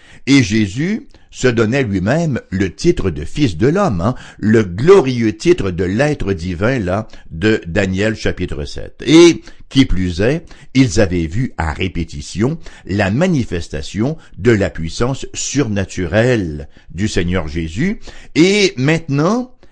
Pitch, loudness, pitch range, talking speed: 110 Hz, -16 LUFS, 90-140 Hz, 130 wpm